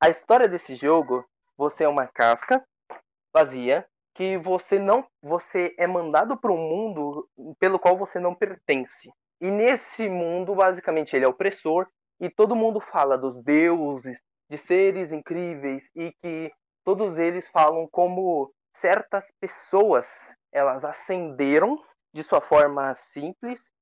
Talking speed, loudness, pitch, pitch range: 135 wpm, -23 LUFS, 175 Hz, 150-195 Hz